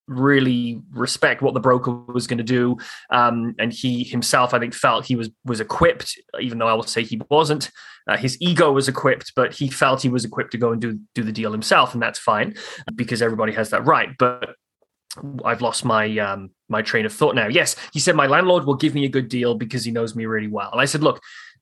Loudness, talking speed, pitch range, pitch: -20 LUFS, 235 wpm, 115-130 Hz, 120 Hz